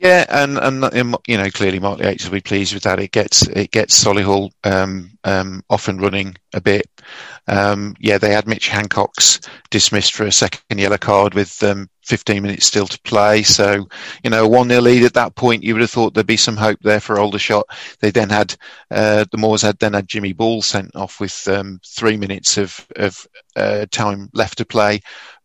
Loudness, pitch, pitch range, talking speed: -15 LUFS, 105 Hz, 100-110 Hz, 210 wpm